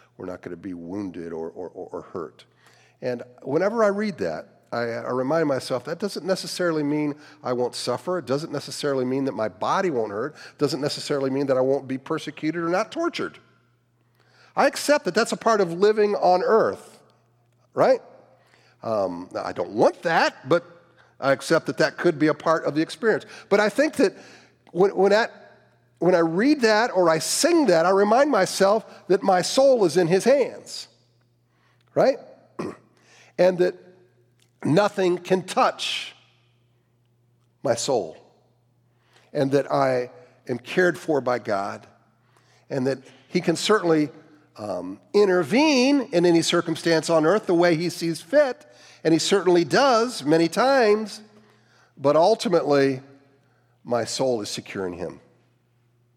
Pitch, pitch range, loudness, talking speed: 160 Hz, 125-190 Hz, -22 LUFS, 155 wpm